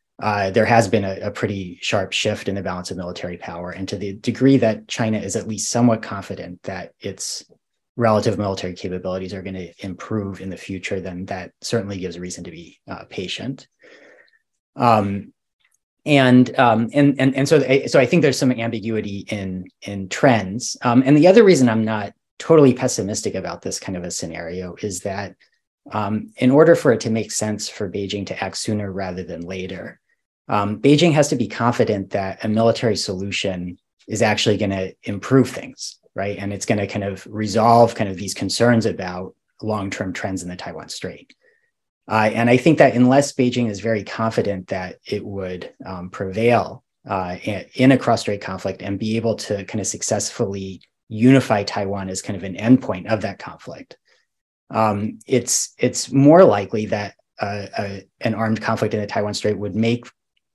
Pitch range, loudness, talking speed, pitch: 95-115 Hz, -19 LUFS, 185 wpm, 105 Hz